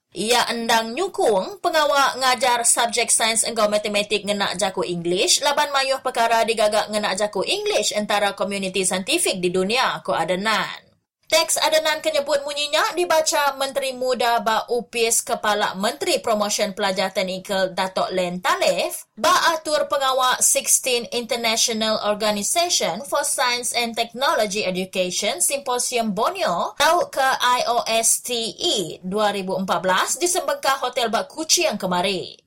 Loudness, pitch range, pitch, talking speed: -20 LUFS, 210-285 Hz, 235 Hz, 120 wpm